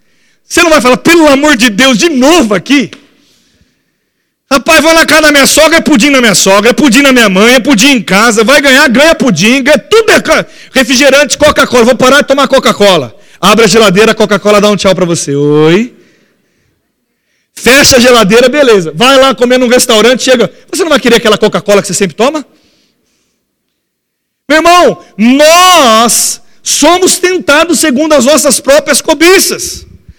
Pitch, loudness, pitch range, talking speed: 265 Hz, -5 LUFS, 220-300 Hz, 170 wpm